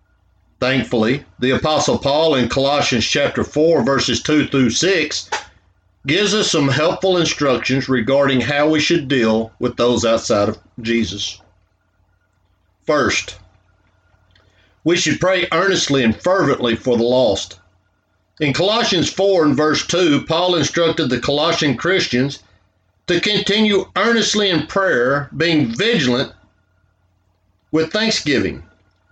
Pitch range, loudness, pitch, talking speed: 95-155 Hz, -16 LUFS, 125 Hz, 115 wpm